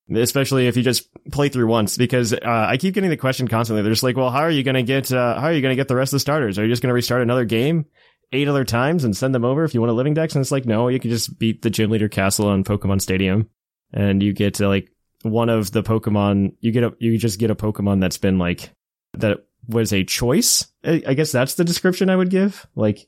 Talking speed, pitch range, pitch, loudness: 275 wpm, 110-135 Hz, 120 Hz, -19 LUFS